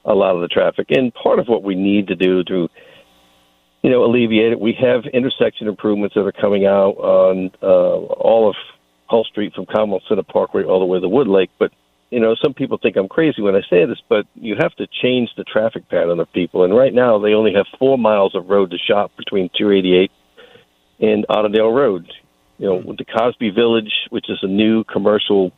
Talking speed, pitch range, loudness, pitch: 220 wpm, 95-115 Hz, -16 LUFS, 105 Hz